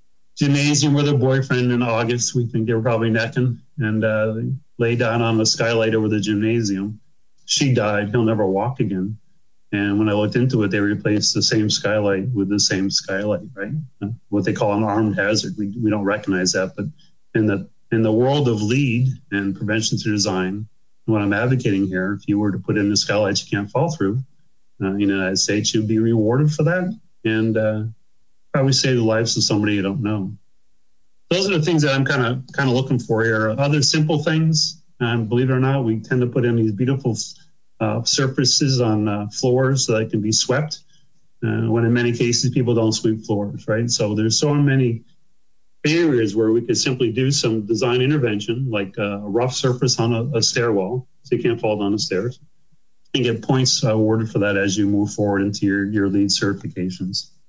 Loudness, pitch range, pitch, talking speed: -19 LUFS, 105-130 Hz, 115 Hz, 205 wpm